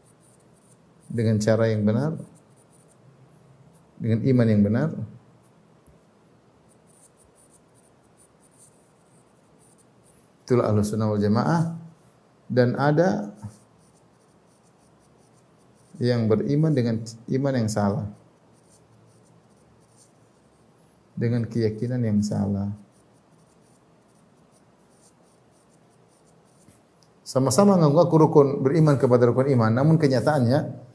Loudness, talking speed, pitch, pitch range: -22 LUFS, 60 wpm, 125 Hz, 110-150 Hz